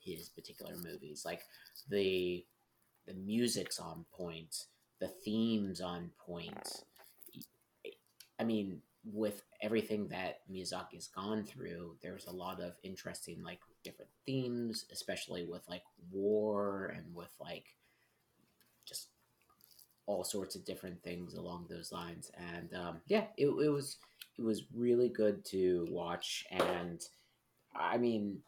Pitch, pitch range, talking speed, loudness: 100 Hz, 90-110 Hz, 125 wpm, -40 LUFS